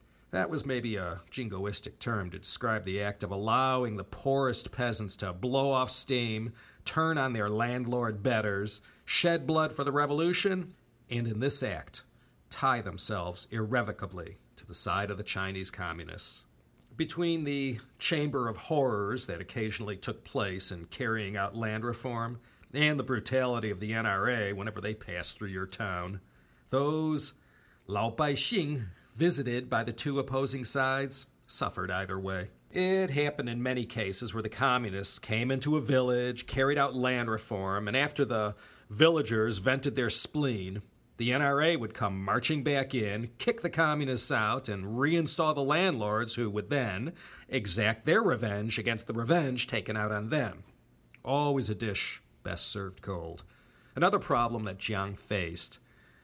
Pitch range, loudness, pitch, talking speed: 100-135 Hz, -30 LUFS, 115 Hz, 155 wpm